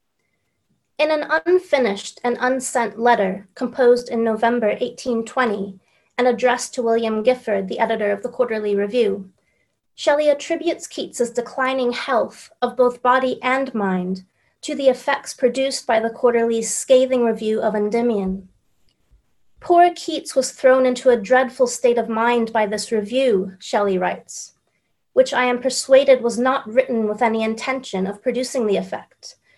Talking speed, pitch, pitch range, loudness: 145 wpm, 245 Hz, 220-260 Hz, -19 LUFS